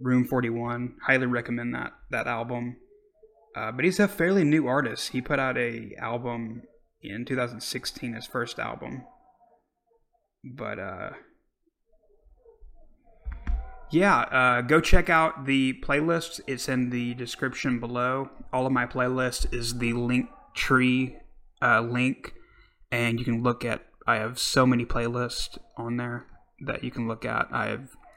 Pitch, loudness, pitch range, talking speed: 125 Hz, -27 LUFS, 120-145 Hz, 145 wpm